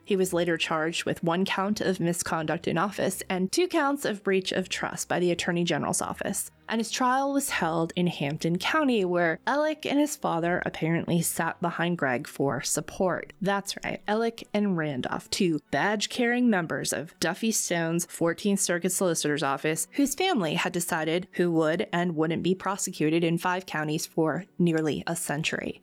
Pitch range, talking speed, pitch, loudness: 165-205 Hz, 170 wpm, 175 Hz, -27 LUFS